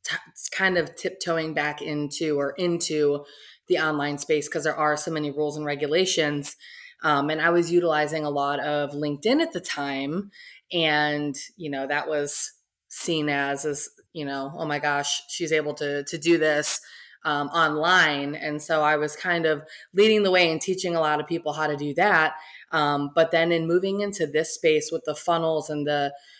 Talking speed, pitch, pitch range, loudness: 190 wpm, 155 Hz, 145-170 Hz, -23 LUFS